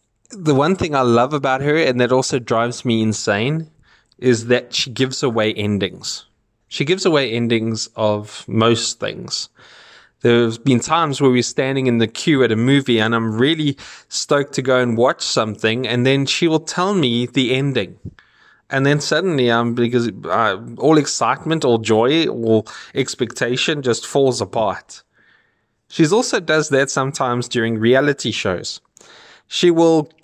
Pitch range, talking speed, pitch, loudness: 115-140 Hz, 160 wpm, 125 Hz, -17 LUFS